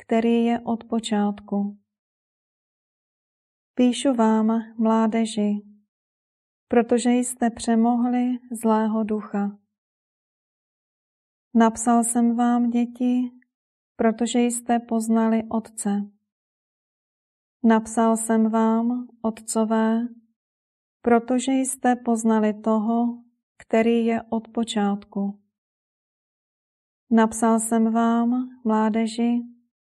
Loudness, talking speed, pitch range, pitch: -22 LUFS, 70 wpm, 220-240 Hz, 230 Hz